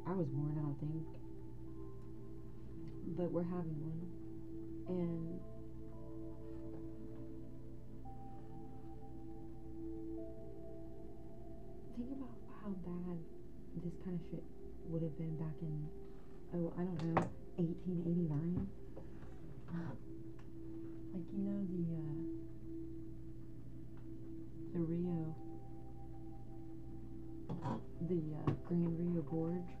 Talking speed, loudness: 85 wpm, -45 LUFS